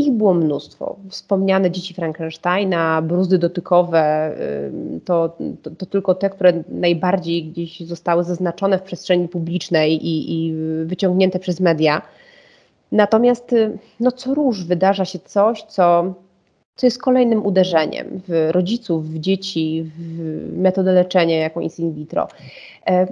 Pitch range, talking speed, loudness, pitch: 165-195 Hz, 130 wpm, -19 LUFS, 180 Hz